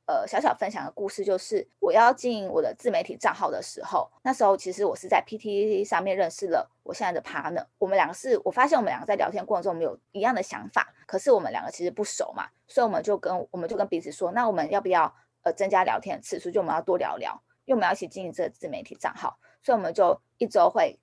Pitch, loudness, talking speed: 215 Hz, -26 LUFS, 415 characters per minute